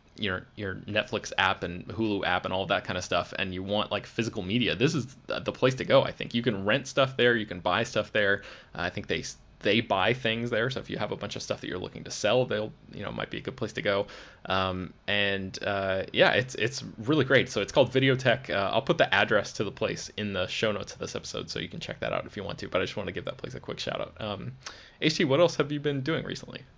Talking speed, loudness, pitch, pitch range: 285 wpm, -28 LUFS, 110 Hz, 95-125 Hz